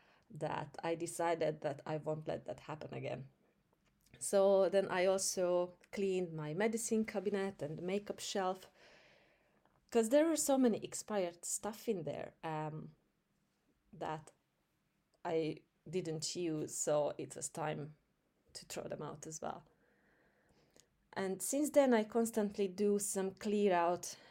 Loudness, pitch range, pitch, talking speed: -37 LUFS, 160-205 Hz, 185 Hz, 135 wpm